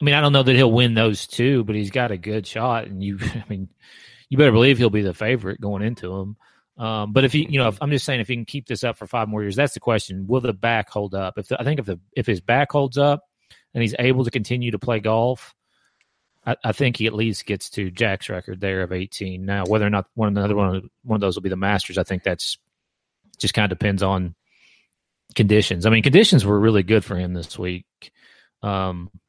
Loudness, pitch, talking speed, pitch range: -21 LUFS, 110 Hz, 245 wpm, 100-125 Hz